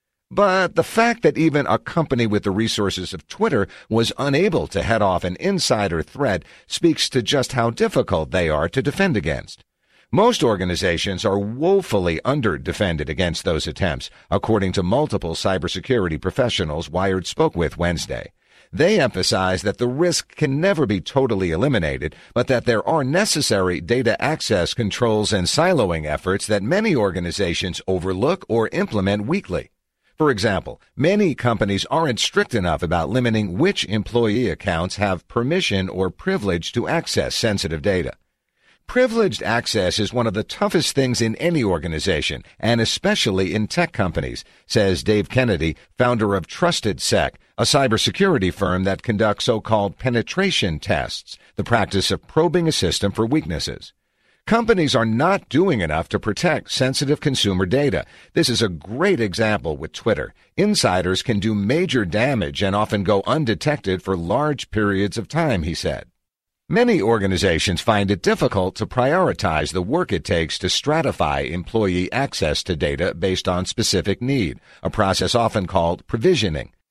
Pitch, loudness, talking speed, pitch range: 105 Hz, -20 LUFS, 150 wpm, 95-135 Hz